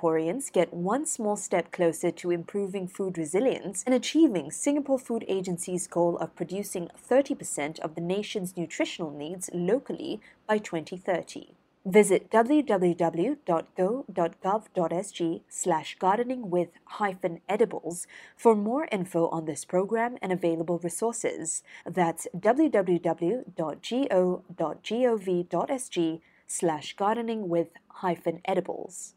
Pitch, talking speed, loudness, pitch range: 185 Hz, 100 wpm, -28 LUFS, 170-215 Hz